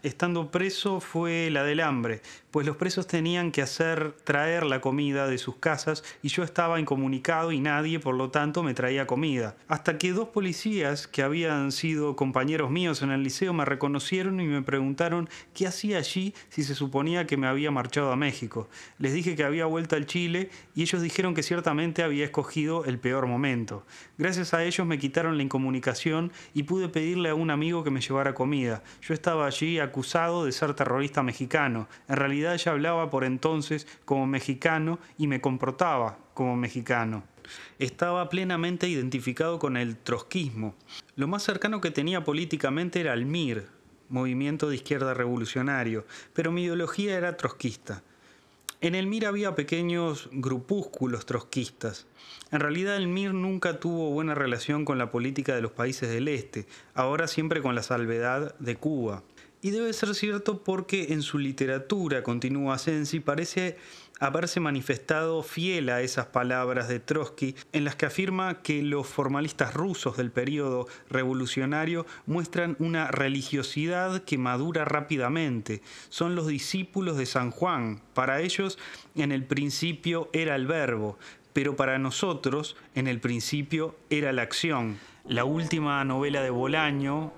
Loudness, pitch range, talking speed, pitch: -28 LUFS, 130-170 Hz, 160 wpm, 150 Hz